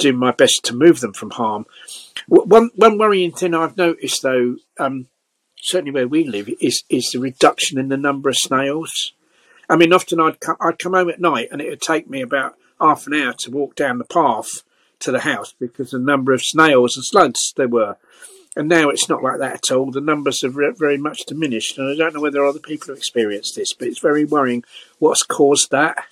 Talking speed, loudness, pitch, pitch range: 225 wpm, -17 LUFS, 145 Hz, 135-170 Hz